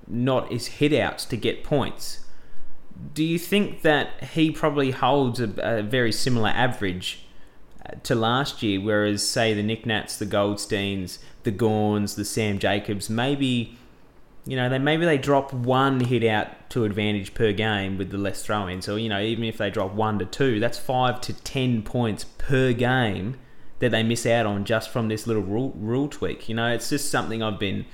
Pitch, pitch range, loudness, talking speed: 115 Hz, 105-130 Hz, -24 LUFS, 185 wpm